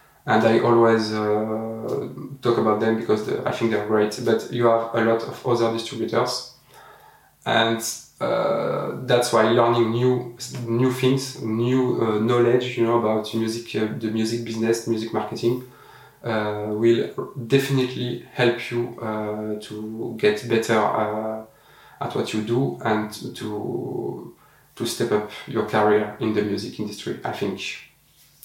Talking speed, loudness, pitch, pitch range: 145 wpm, -23 LUFS, 115 Hz, 110-120 Hz